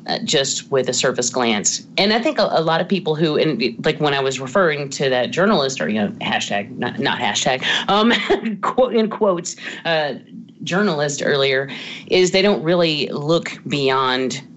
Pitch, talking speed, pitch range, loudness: 165 Hz, 180 wpm, 140-210 Hz, -18 LUFS